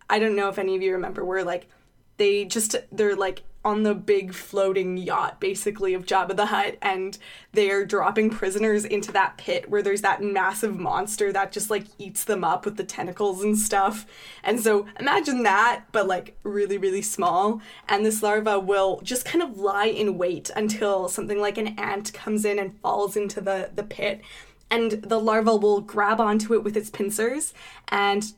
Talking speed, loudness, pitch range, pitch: 190 wpm, -24 LUFS, 195-215 Hz, 205 Hz